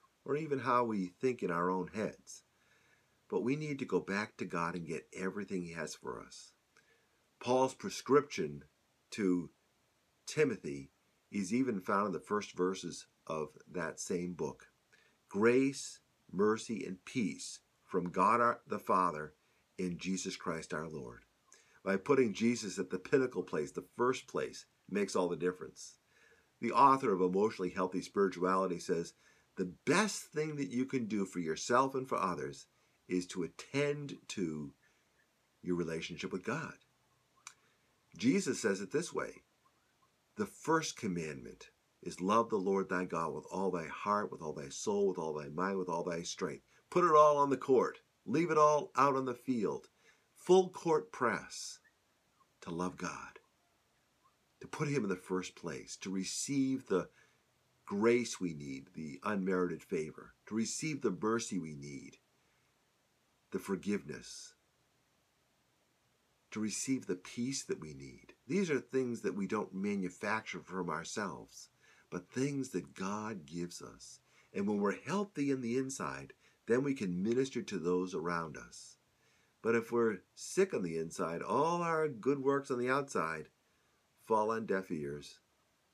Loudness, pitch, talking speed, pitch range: -36 LUFS, 105 Hz, 155 wpm, 90-135 Hz